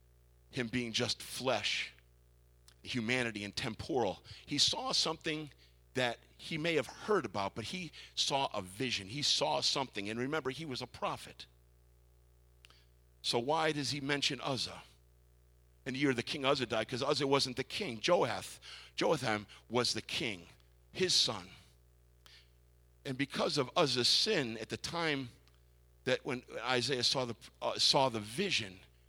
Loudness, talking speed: -34 LUFS, 150 wpm